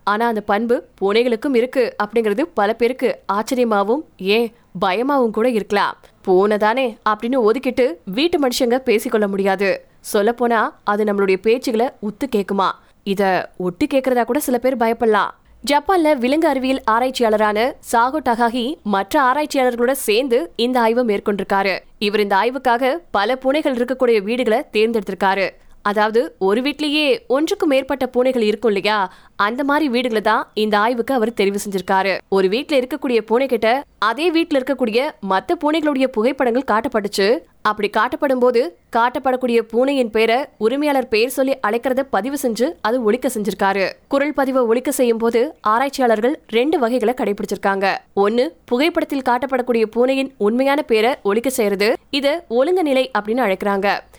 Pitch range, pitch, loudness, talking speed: 210-265 Hz, 235 Hz, -18 LUFS, 130 wpm